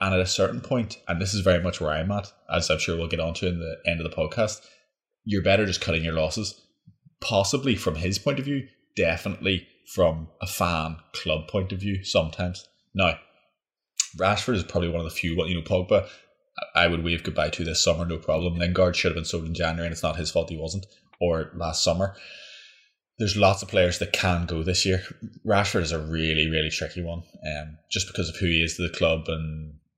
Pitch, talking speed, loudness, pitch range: 85 Hz, 220 wpm, -25 LUFS, 80-95 Hz